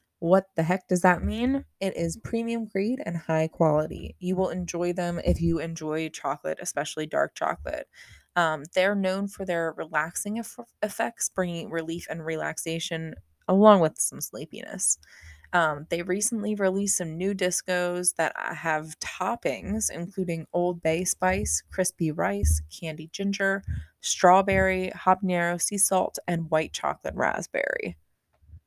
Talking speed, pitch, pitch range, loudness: 140 wpm, 175 Hz, 160-190 Hz, -26 LUFS